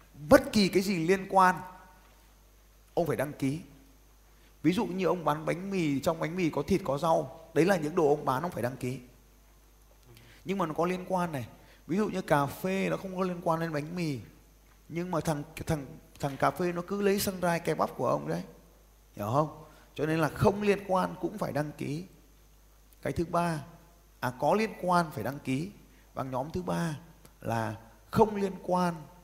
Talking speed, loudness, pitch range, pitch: 205 wpm, -30 LUFS, 140-180 Hz, 165 Hz